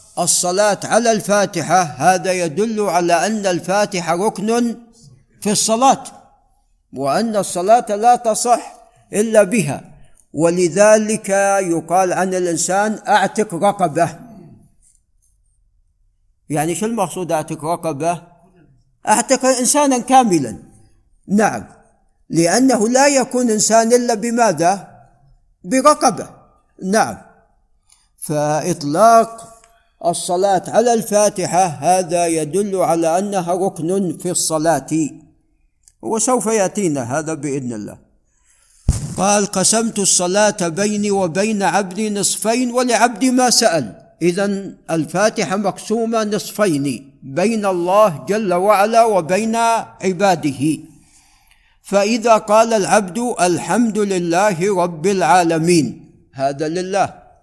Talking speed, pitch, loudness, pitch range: 90 wpm, 195 Hz, -16 LUFS, 170-220 Hz